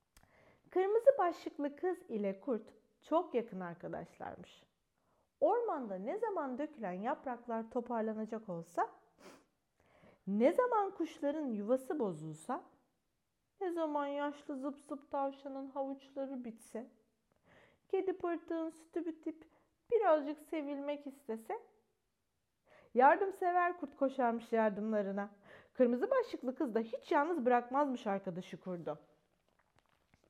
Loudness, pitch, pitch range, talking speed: -37 LUFS, 280 Hz, 225-330 Hz, 95 wpm